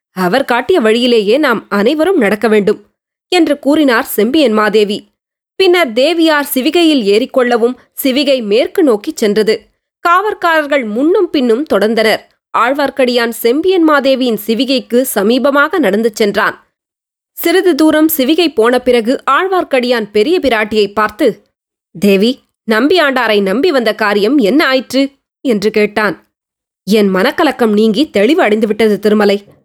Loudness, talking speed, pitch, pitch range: -11 LUFS, 105 wpm, 250 Hz, 215-295 Hz